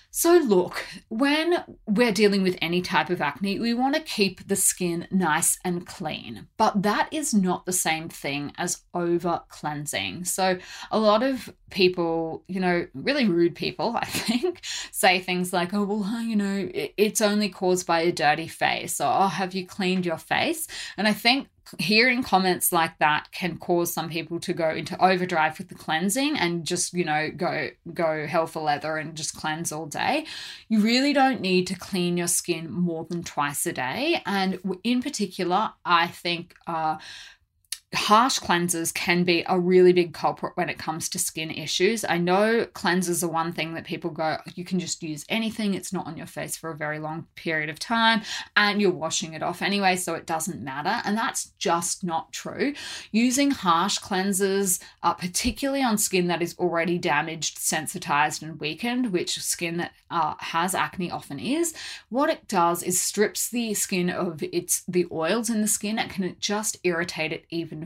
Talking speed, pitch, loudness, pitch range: 185 wpm, 180 Hz, -25 LUFS, 165-205 Hz